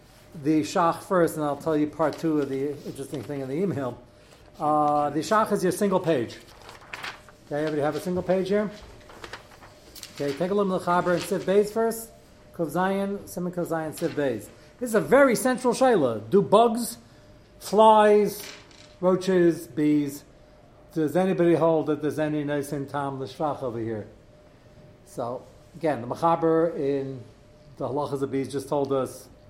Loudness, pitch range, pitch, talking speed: -25 LUFS, 140-180 Hz, 155 Hz, 165 wpm